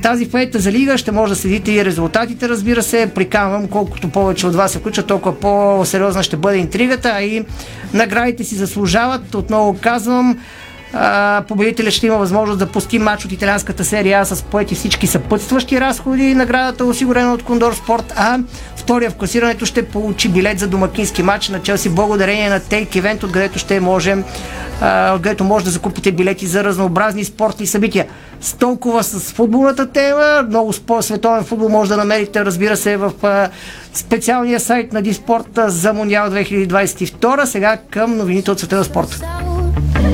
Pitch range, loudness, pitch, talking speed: 195-230 Hz, -15 LUFS, 210 Hz, 160 wpm